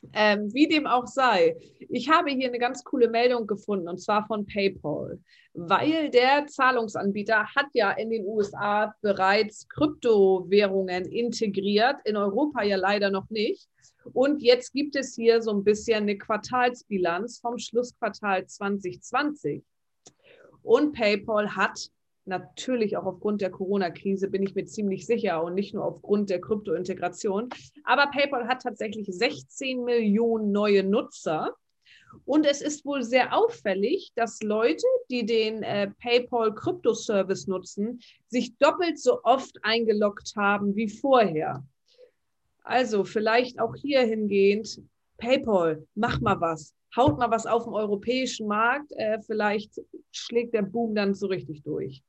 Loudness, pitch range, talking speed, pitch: -25 LUFS, 200-250 Hz, 145 wpm, 220 Hz